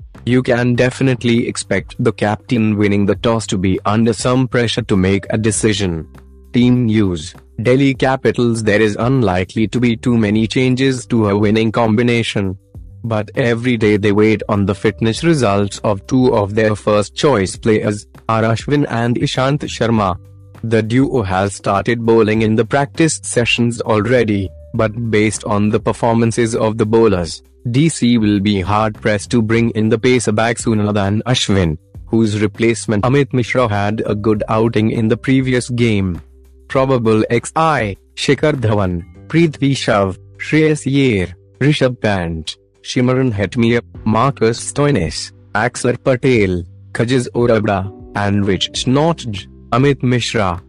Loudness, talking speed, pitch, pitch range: -15 LUFS, 140 wpm, 110 Hz, 100-125 Hz